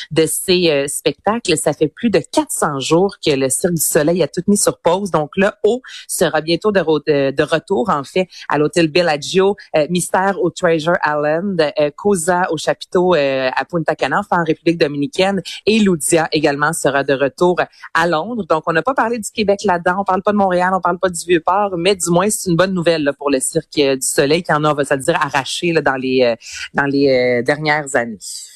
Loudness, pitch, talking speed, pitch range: -16 LUFS, 165 Hz, 235 wpm, 150-185 Hz